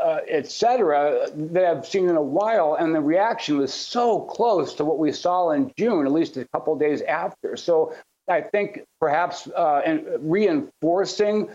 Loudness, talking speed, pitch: -22 LUFS, 170 wpm, 230 Hz